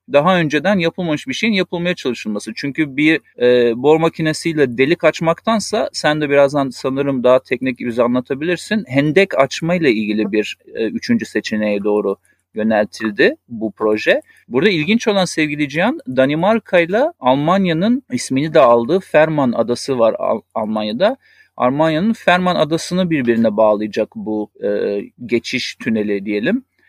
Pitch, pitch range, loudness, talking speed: 145 Hz, 120-180 Hz, -16 LUFS, 135 wpm